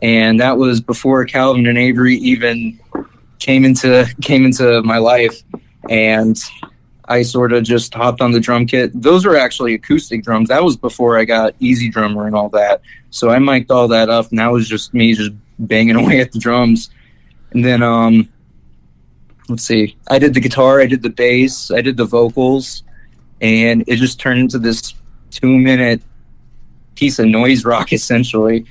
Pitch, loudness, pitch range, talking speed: 120 Hz, -12 LUFS, 110-125 Hz, 180 wpm